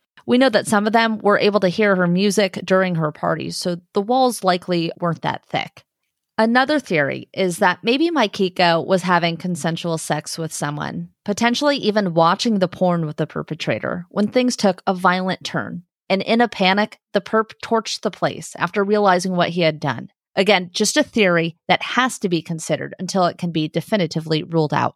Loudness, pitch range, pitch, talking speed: -19 LUFS, 170-210 Hz, 185 Hz, 190 wpm